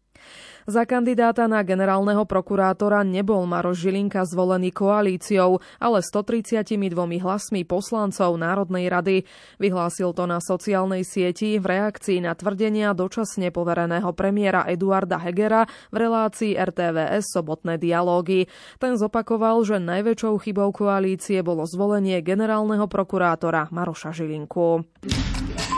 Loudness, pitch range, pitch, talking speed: -22 LUFS, 180-210 Hz, 190 Hz, 110 wpm